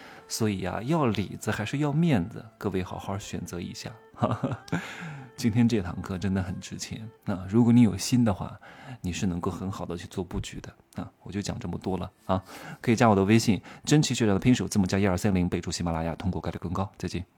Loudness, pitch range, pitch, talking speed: -27 LUFS, 90-115 Hz, 100 Hz, 325 characters per minute